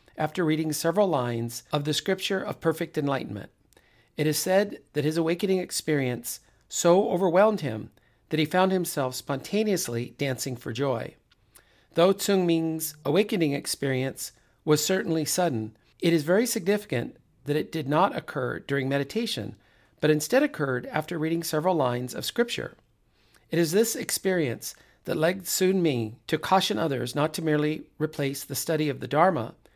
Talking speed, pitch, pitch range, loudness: 155 wpm, 155 Hz, 125-180 Hz, -26 LUFS